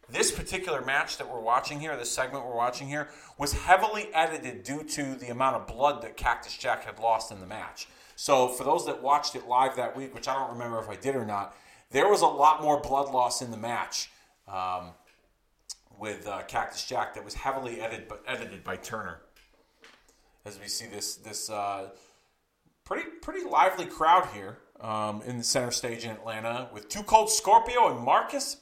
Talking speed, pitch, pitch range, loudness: 195 wpm, 125 Hz, 110-145 Hz, -28 LUFS